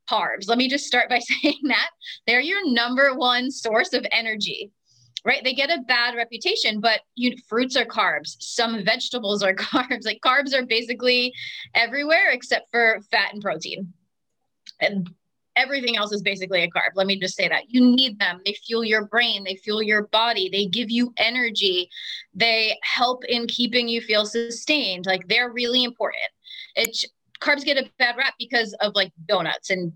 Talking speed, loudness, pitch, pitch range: 180 wpm, -21 LUFS, 235 Hz, 205-250 Hz